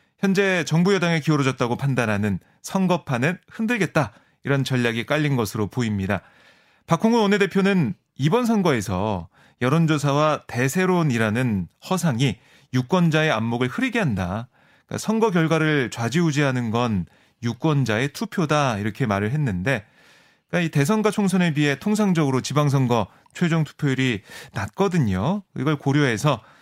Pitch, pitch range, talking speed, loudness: 145 Hz, 120-175 Hz, 335 characters per minute, -22 LUFS